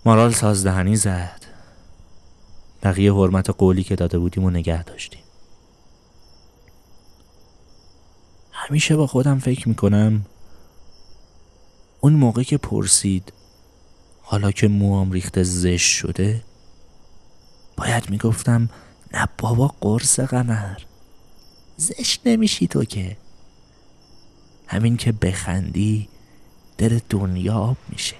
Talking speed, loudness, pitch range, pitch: 95 wpm, -19 LUFS, 85-110 Hz, 95 Hz